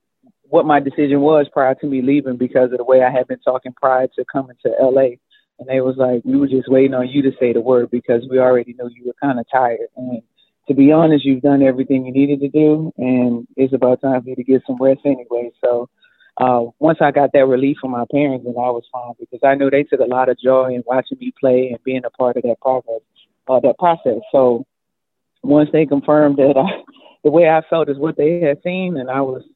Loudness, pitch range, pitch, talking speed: -16 LUFS, 125-145 Hz, 130 Hz, 250 wpm